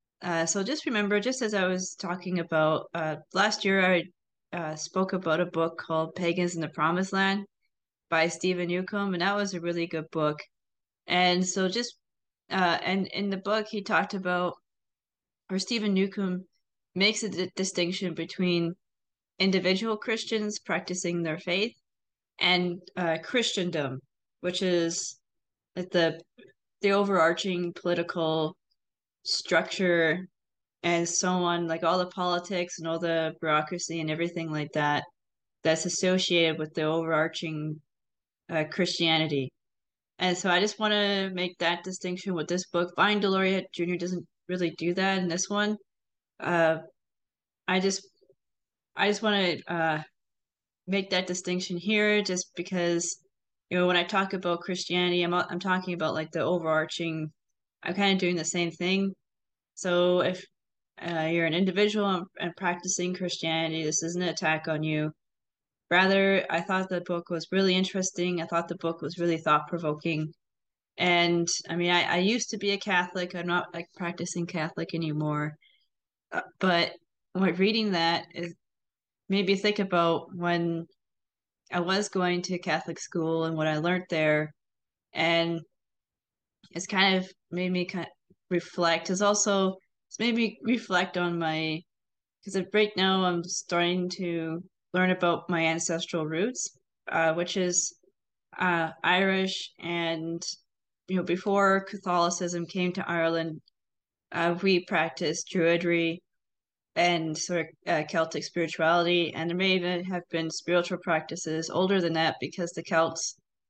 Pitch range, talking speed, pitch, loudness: 165-190 Hz, 150 wpm, 175 Hz, -28 LUFS